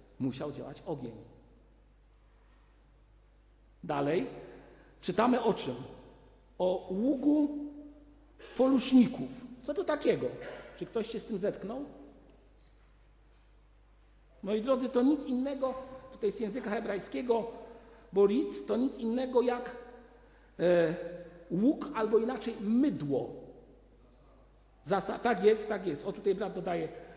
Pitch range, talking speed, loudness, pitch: 170-255 Hz, 105 wpm, -32 LUFS, 220 Hz